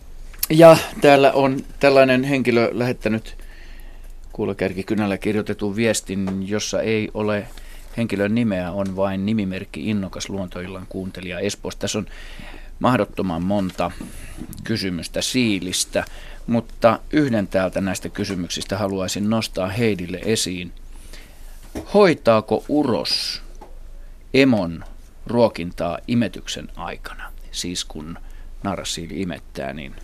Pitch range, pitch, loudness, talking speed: 90-115 Hz, 100 Hz, -20 LUFS, 95 wpm